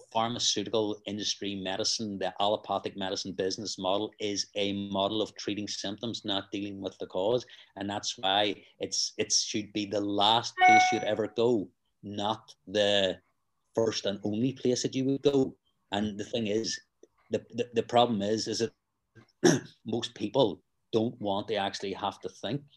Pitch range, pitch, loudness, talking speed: 100-115 Hz, 105 Hz, -30 LUFS, 165 wpm